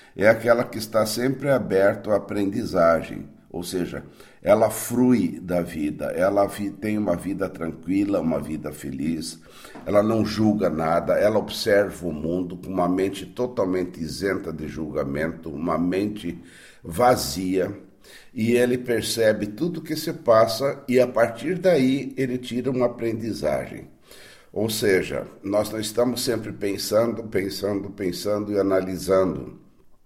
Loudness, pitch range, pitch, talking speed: -23 LUFS, 90-115 Hz, 105 Hz, 135 wpm